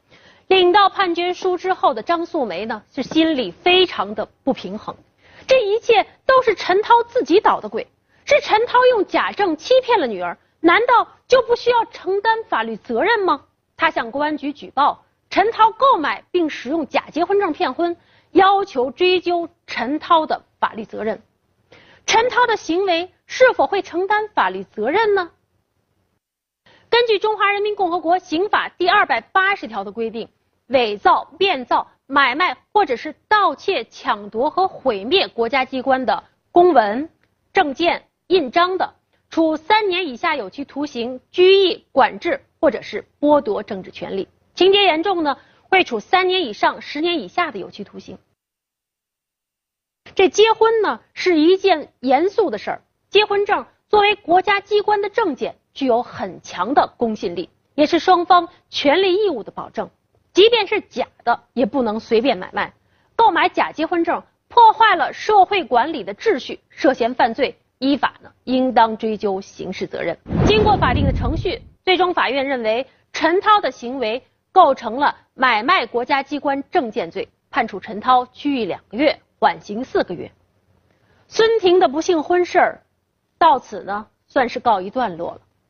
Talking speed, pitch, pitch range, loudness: 240 characters per minute, 355 Hz, 270-400 Hz, -18 LUFS